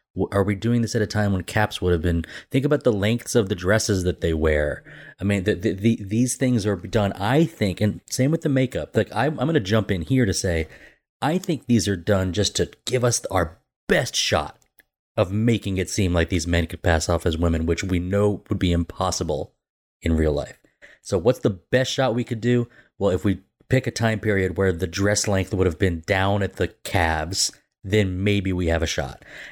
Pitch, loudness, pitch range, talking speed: 100 Hz, -23 LUFS, 90-115 Hz, 230 wpm